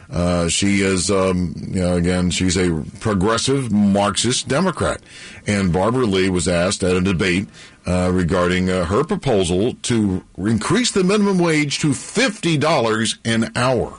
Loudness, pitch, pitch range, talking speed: -18 LUFS, 100 Hz, 90-120 Hz, 145 wpm